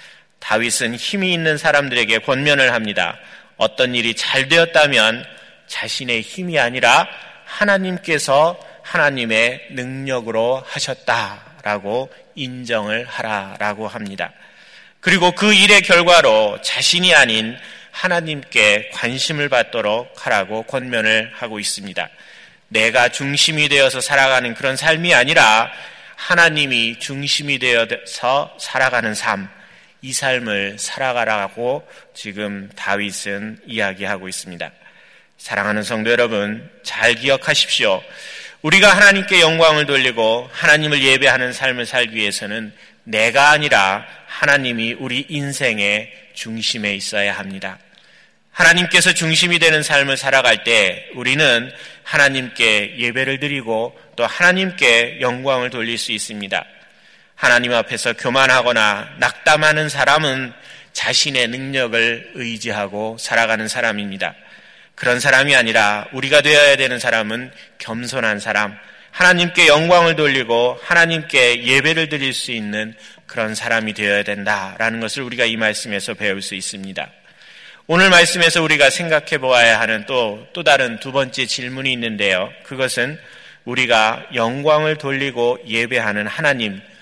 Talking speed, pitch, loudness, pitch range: 295 characters per minute, 125 Hz, -15 LUFS, 110-145 Hz